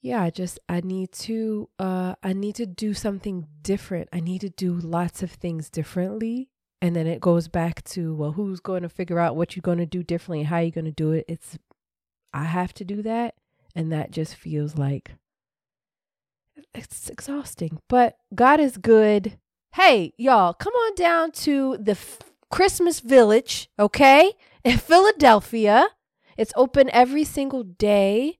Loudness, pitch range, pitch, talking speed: -21 LUFS, 170-240 Hz, 195 Hz, 175 wpm